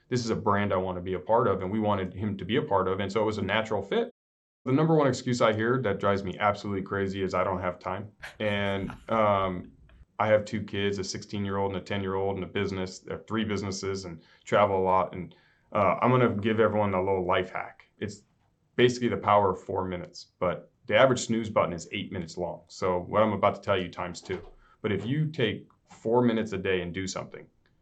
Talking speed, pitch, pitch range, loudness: 250 wpm, 100 Hz, 95-110 Hz, -28 LUFS